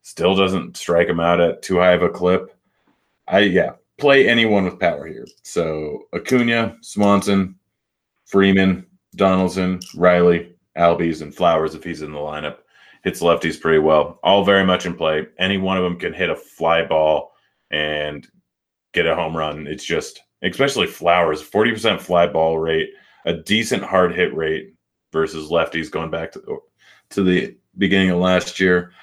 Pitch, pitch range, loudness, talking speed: 90 Hz, 80-95 Hz, -18 LUFS, 165 wpm